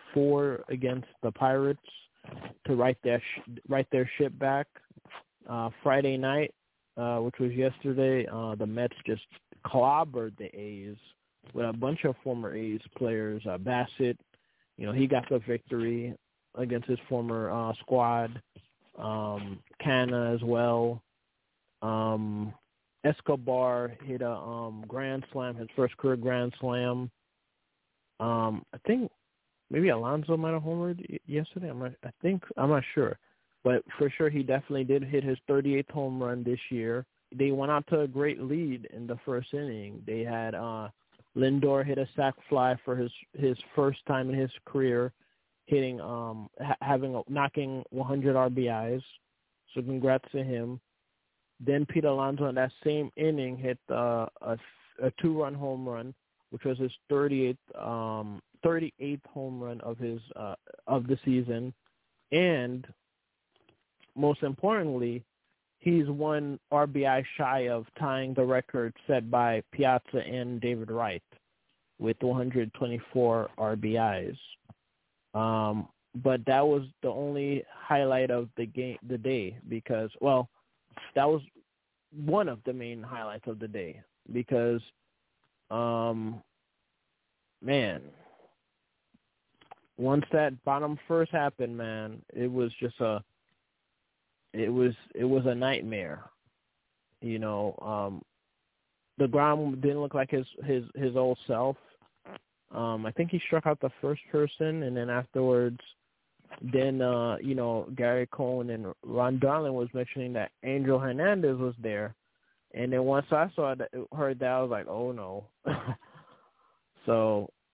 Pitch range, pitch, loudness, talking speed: 115-140 Hz, 125 Hz, -30 LUFS, 140 wpm